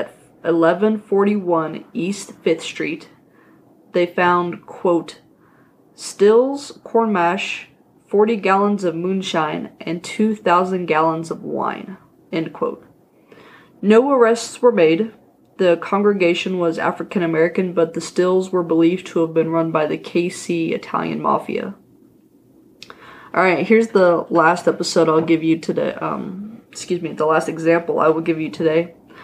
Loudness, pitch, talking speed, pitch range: -18 LUFS, 175 Hz, 130 wpm, 165-200 Hz